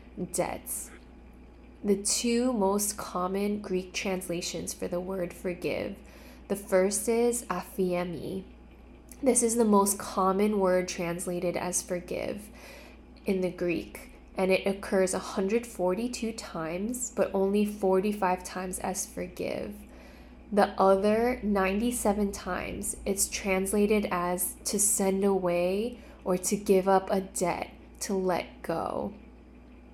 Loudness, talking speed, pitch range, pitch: -29 LUFS, 115 wpm, 180-210 Hz, 195 Hz